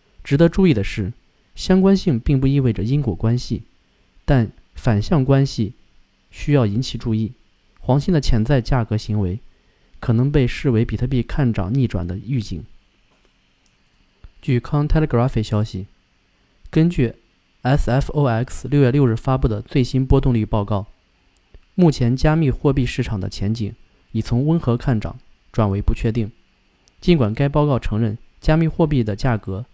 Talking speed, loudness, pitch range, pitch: 250 characters per minute, -20 LUFS, 105-140 Hz, 120 Hz